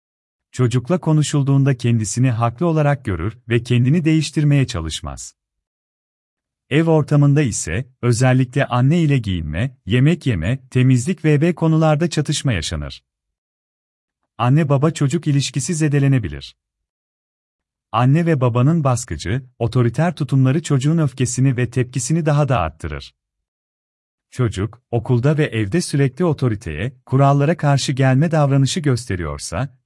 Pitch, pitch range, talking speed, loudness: 130 Hz, 95-150 Hz, 105 wpm, -18 LUFS